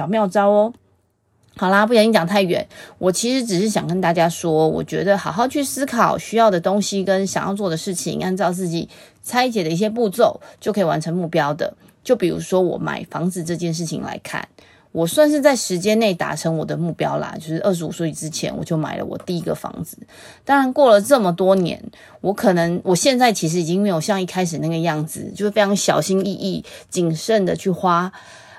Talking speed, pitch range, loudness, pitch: 315 characters per minute, 170-215 Hz, -19 LUFS, 190 Hz